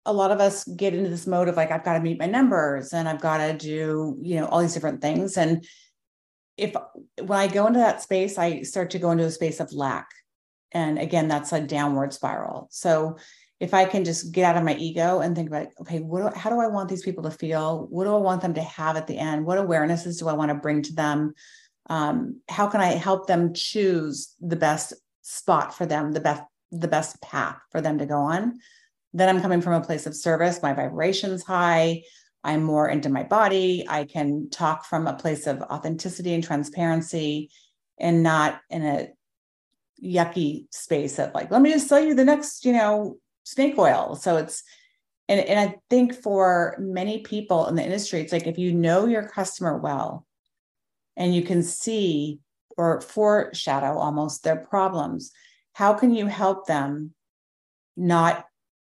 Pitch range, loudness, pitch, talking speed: 155-195 Hz, -24 LUFS, 170 Hz, 200 wpm